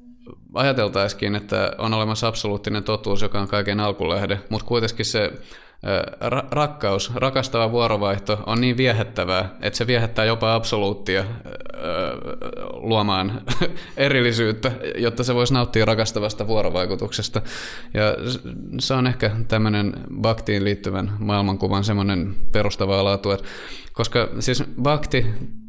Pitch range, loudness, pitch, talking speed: 100-120 Hz, -22 LUFS, 110 Hz, 110 wpm